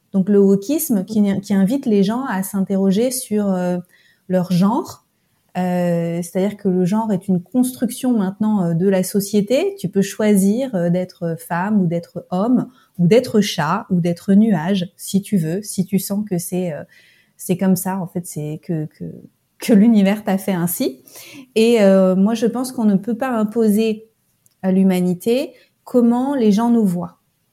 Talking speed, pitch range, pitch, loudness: 175 wpm, 180-220 Hz, 195 Hz, -18 LUFS